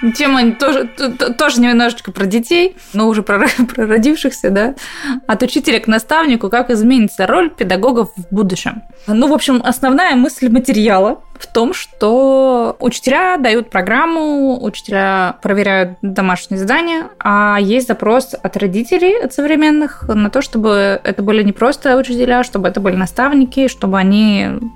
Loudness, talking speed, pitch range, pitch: -13 LUFS, 145 wpm, 205-265 Hz, 235 Hz